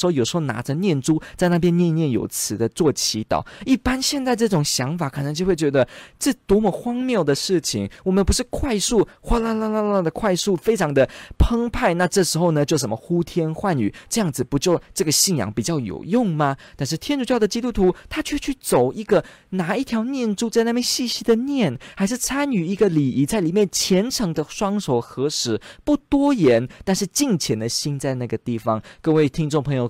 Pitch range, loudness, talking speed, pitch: 145-230 Hz, -21 LUFS, 305 characters per minute, 180 Hz